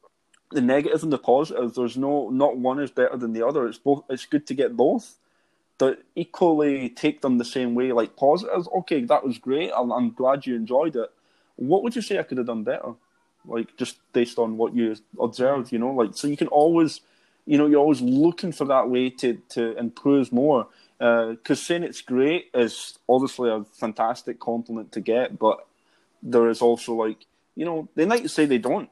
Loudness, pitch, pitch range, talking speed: -23 LUFS, 130 Hz, 120-145 Hz, 205 wpm